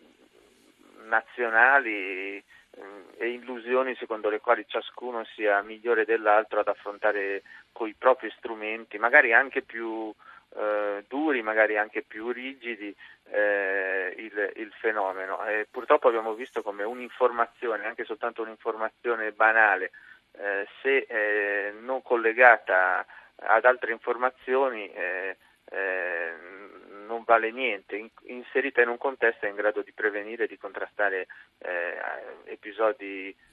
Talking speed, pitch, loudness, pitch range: 120 wpm, 115 Hz, -26 LUFS, 105-125 Hz